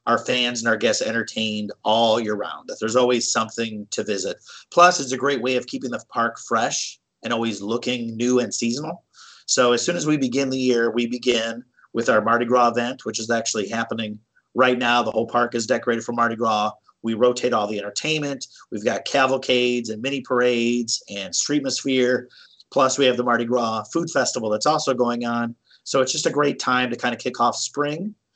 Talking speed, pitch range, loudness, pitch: 205 wpm, 115-125 Hz, -22 LUFS, 120 Hz